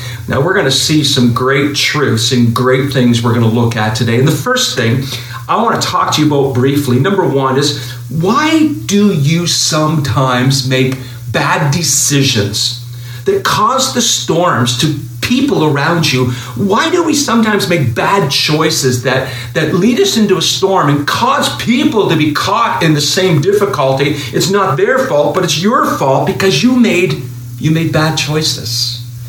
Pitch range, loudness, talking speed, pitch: 125-175 Hz, -11 LUFS, 175 wpm, 140 Hz